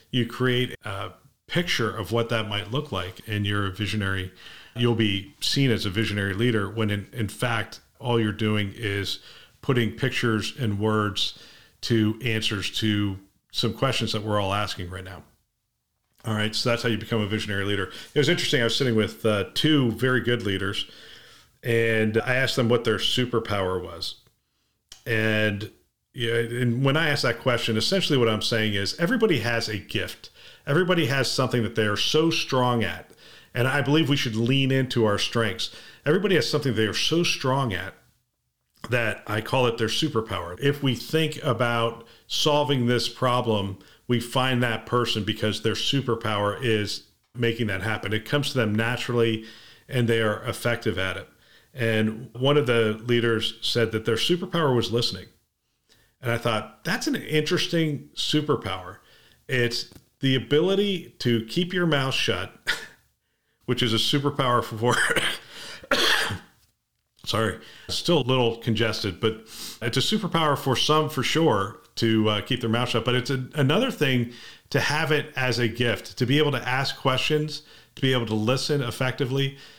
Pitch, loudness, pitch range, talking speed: 115 Hz, -24 LUFS, 110-135 Hz, 170 wpm